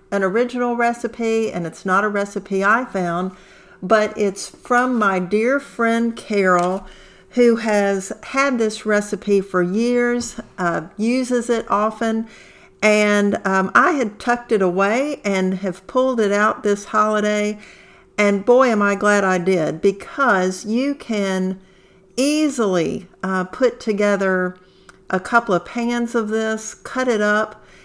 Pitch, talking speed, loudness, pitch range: 210 Hz, 140 wpm, -19 LUFS, 190-235 Hz